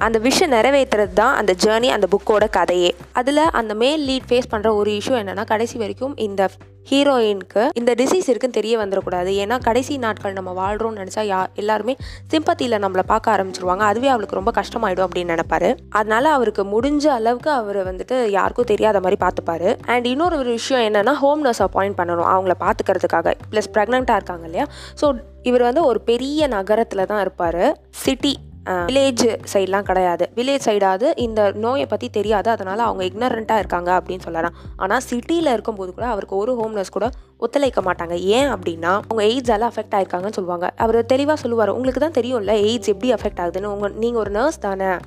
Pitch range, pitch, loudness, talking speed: 195-250 Hz, 215 Hz, -19 LUFS, 170 wpm